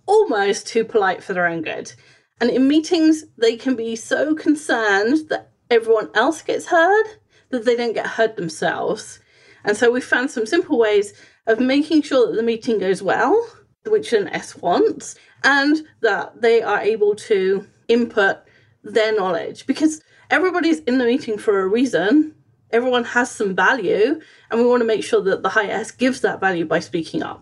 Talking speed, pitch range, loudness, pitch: 180 wpm, 225-360 Hz, -19 LUFS, 255 Hz